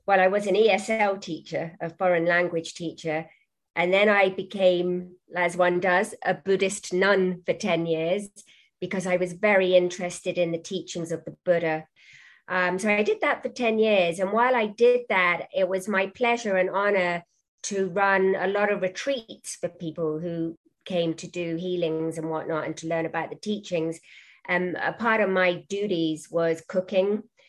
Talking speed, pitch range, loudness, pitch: 180 wpm, 170-200 Hz, -25 LUFS, 185 Hz